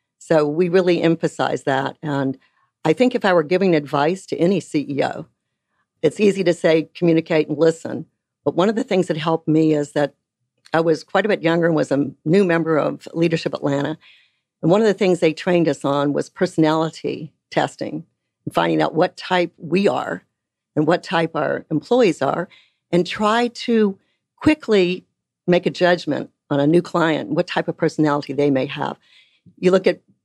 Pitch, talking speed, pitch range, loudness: 165 Hz, 185 wpm, 150-180 Hz, -19 LUFS